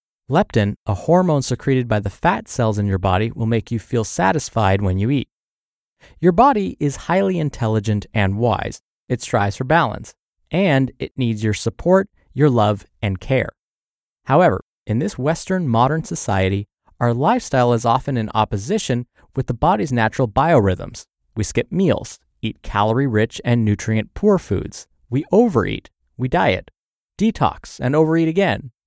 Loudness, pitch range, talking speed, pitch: -19 LUFS, 110-150 Hz, 155 wpm, 120 Hz